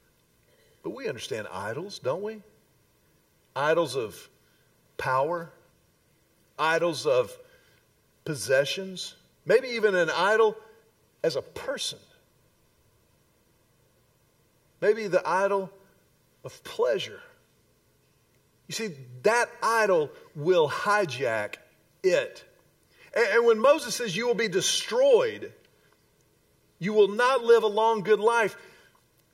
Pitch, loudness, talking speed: 235 Hz, -26 LUFS, 95 wpm